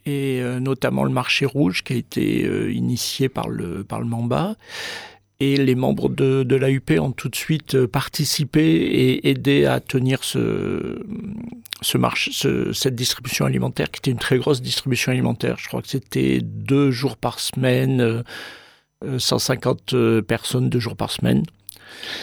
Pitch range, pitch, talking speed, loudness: 115-140 Hz, 130 Hz, 155 wpm, -21 LUFS